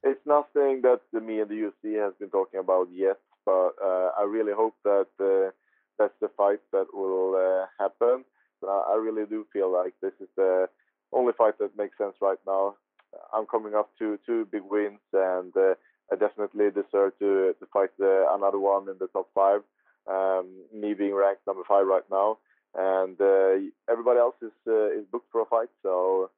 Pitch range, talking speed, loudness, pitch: 95-115 Hz, 195 wpm, -26 LUFS, 100 Hz